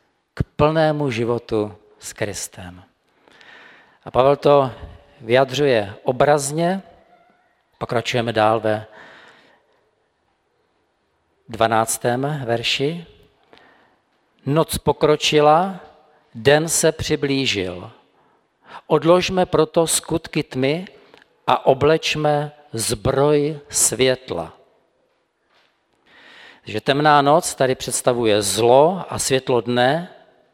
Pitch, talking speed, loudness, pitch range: 140 Hz, 70 wpm, -19 LUFS, 115-155 Hz